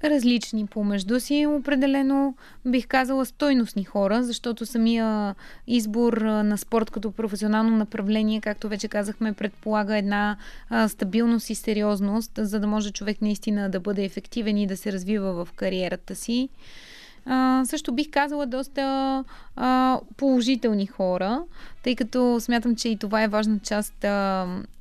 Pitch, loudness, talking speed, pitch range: 220 Hz, -25 LUFS, 140 wpm, 210-255 Hz